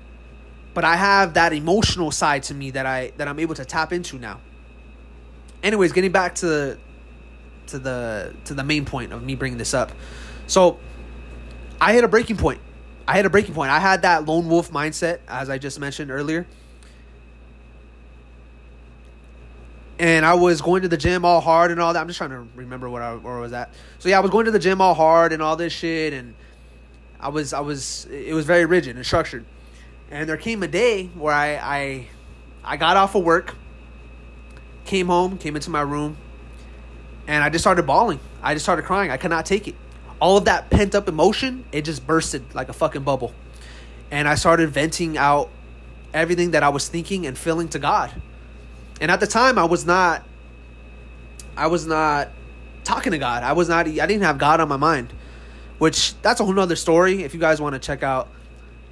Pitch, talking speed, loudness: 145 Hz, 205 wpm, -20 LUFS